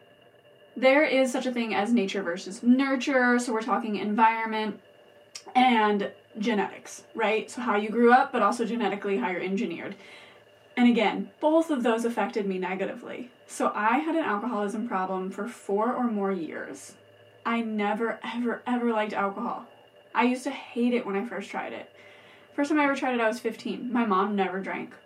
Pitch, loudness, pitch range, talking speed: 220 Hz, -26 LUFS, 200-245 Hz, 180 wpm